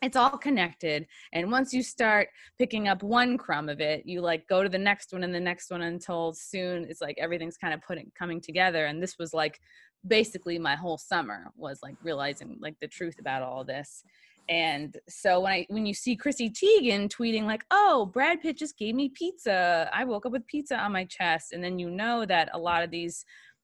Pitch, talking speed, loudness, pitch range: 185 Hz, 220 wpm, -28 LUFS, 165-230 Hz